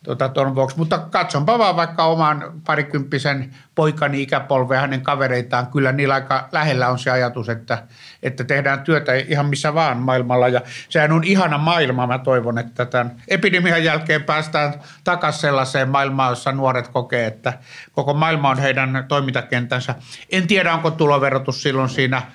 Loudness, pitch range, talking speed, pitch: -19 LUFS, 130-155 Hz, 155 wpm, 140 Hz